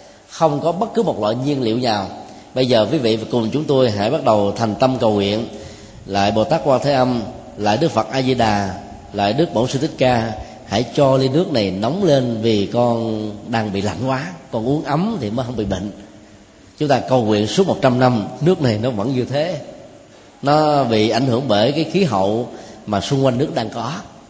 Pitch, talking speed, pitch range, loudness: 120 Hz, 220 wpm, 105-140 Hz, -18 LUFS